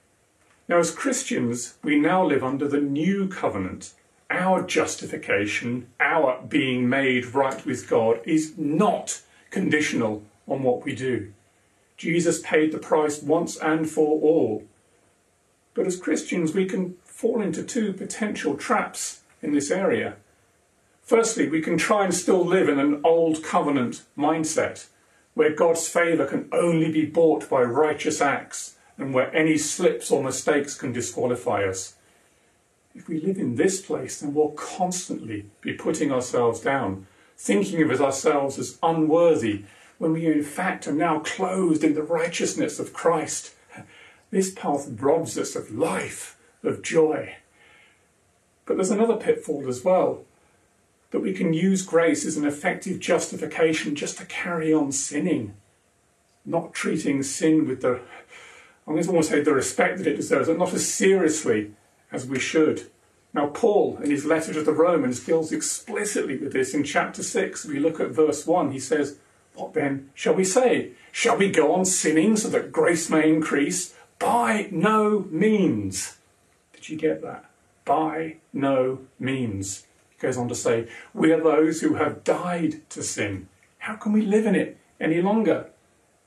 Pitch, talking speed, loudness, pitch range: 155 Hz, 155 wpm, -24 LUFS, 135-180 Hz